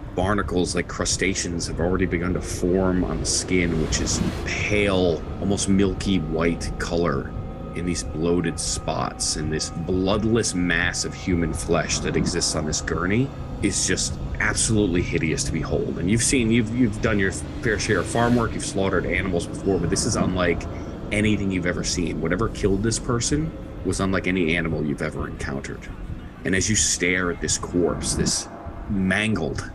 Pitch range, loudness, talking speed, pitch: 85-100 Hz, -23 LUFS, 170 wpm, 90 Hz